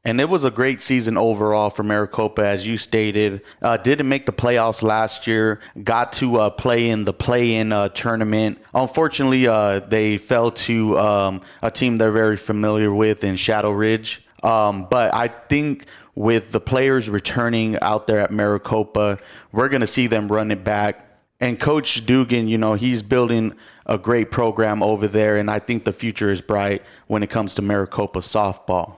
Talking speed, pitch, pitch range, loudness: 185 wpm, 110 Hz, 105-120 Hz, -19 LUFS